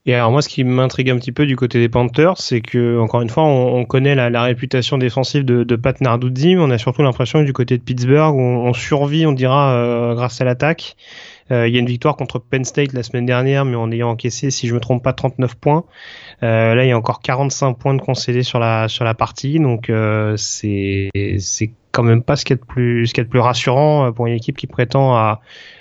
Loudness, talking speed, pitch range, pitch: -16 LUFS, 255 wpm, 120-135 Hz, 125 Hz